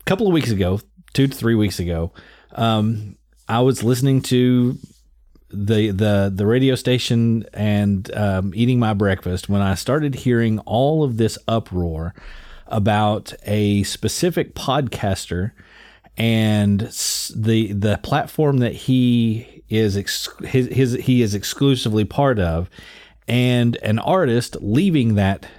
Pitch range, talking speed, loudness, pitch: 100-125 Hz, 130 wpm, -19 LUFS, 110 Hz